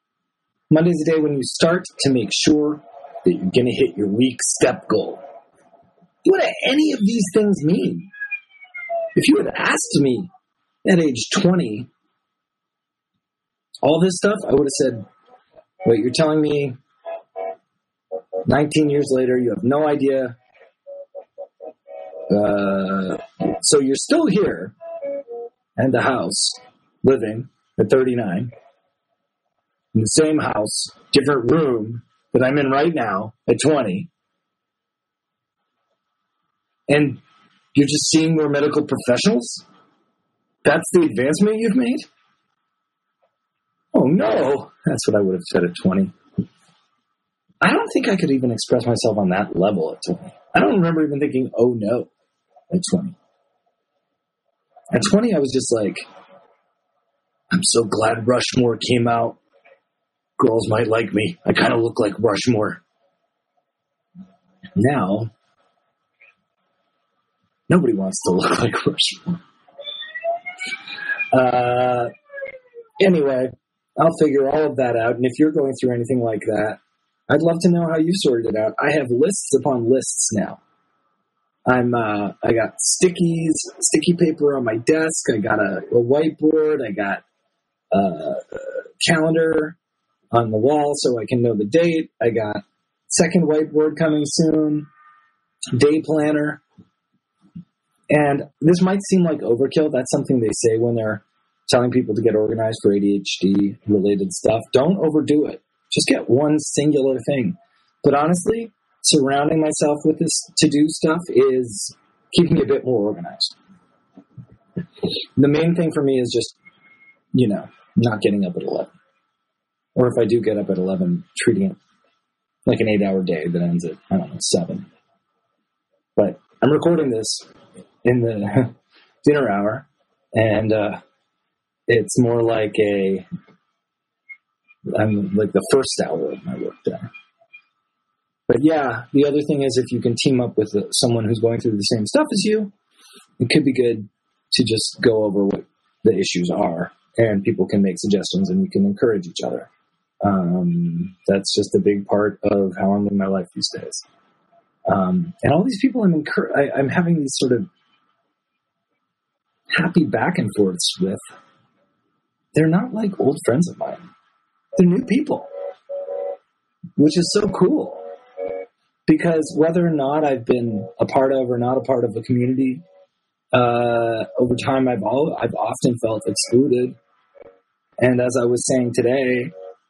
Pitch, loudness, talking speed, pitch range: 140 Hz, -19 LUFS, 145 wpm, 115-175 Hz